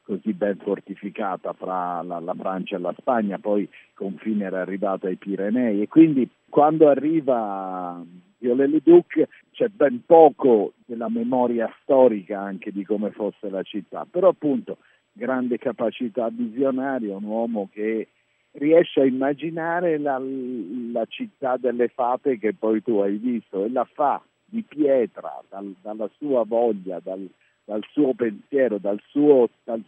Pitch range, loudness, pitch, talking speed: 100-140 Hz, -22 LUFS, 115 Hz, 145 wpm